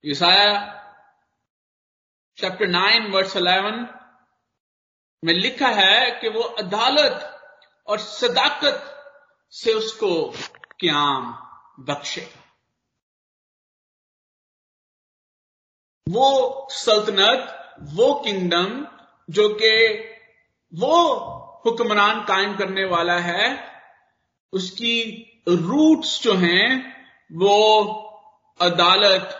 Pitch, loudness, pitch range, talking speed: 220 Hz, -19 LUFS, 195-270 Hz, 70 wpm